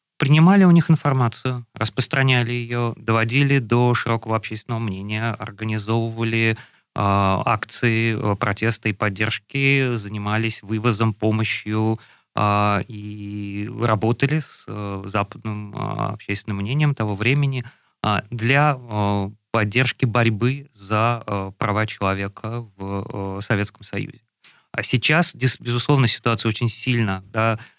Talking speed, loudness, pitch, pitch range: 110 wpm, -21 LUFS, 115 Hz, 105-125 Hz